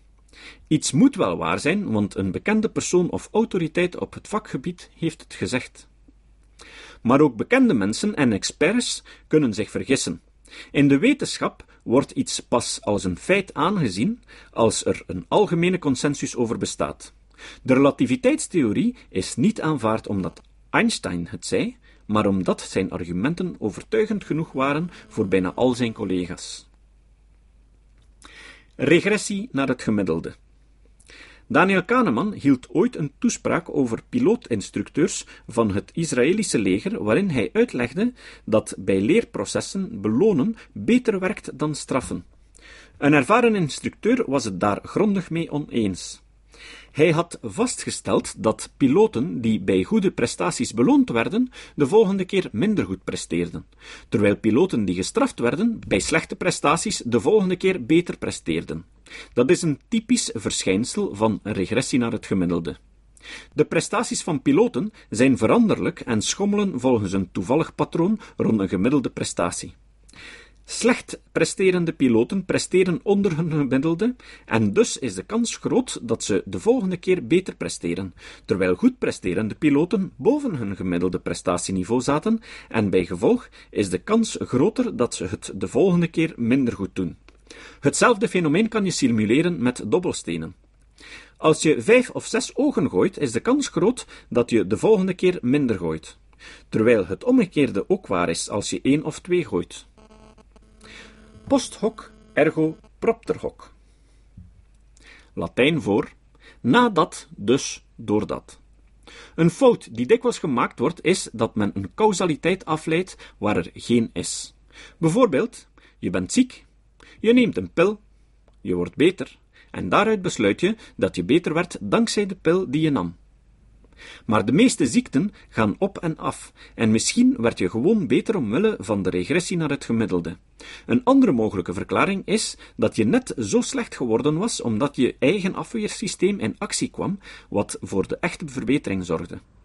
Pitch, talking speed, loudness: 165 Hz, 145 wpm, -22 LUFS